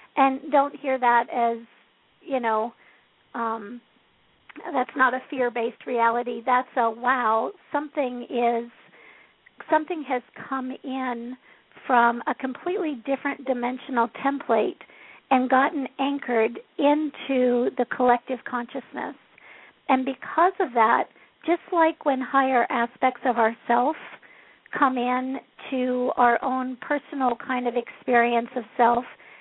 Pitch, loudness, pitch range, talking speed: 255 Hz, -24 LUFS, 240-275 Hz, 120 wpm